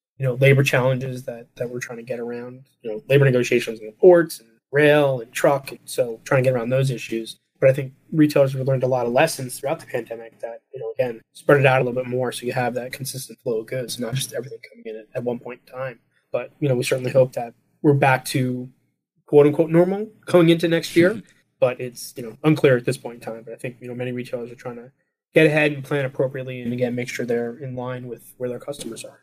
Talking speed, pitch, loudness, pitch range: 260 wpm, 130 Hz, -21 LUFS, 120-145 Hz